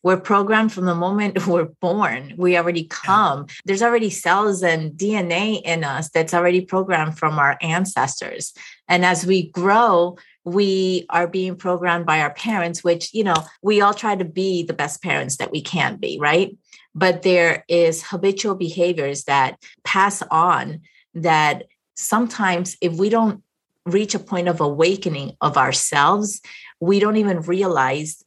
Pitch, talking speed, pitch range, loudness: 180 Hz, 155 wpm, 165-195 Hz, -19 LUFS